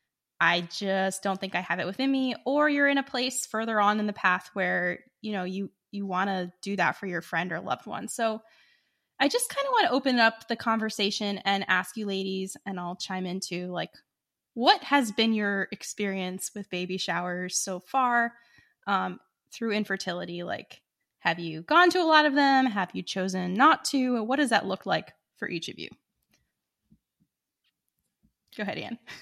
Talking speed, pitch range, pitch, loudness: 190 wpm, 185-240 Hz, 200 Hz, -27 LUFS